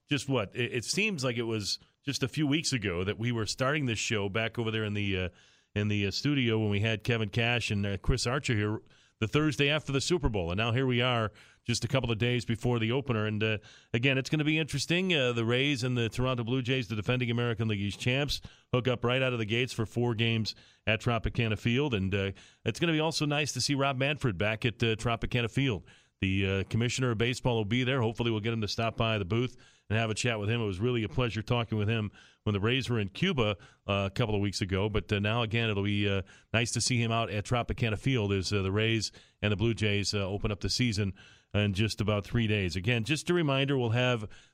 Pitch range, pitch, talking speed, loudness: 105-125 Hz, 115 Hz, 250 wpm, -30 LUFS